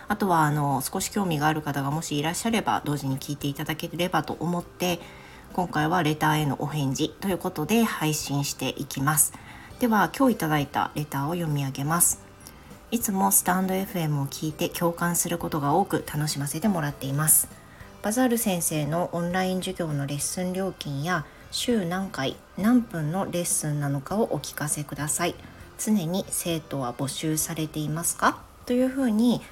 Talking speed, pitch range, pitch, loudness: 370 characters per minute, 145-185 Hz, 160 Hz, -26 LUFS